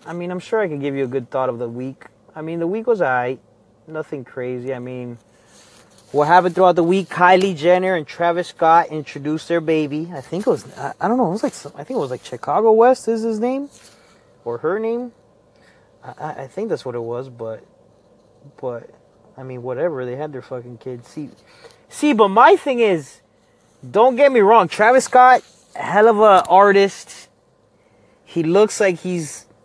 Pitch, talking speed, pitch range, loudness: 170 Hz, 200 wpm, 130-215 Hz, -17 LUFS